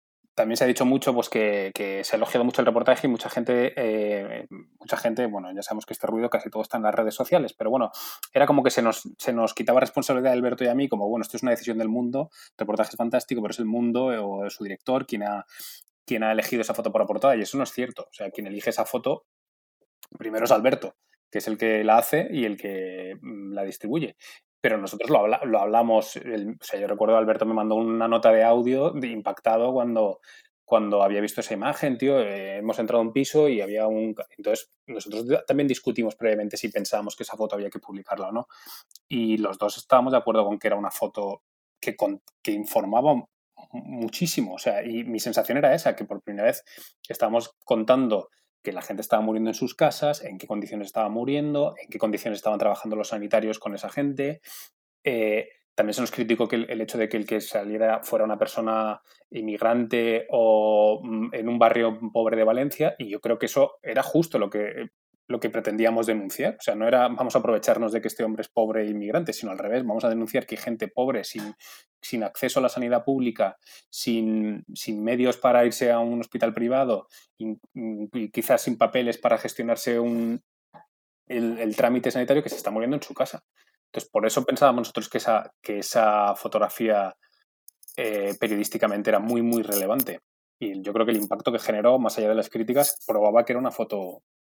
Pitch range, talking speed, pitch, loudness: 110-125 Hz, 215 wpm, 115 Hz, -25 LUFS